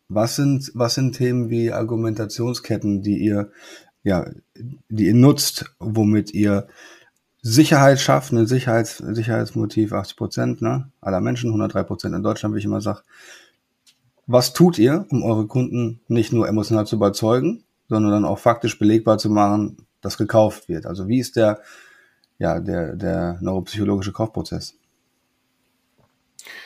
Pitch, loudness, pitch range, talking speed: 110 Hz, -20 LUFS, 105-120 Hz, 140 wpm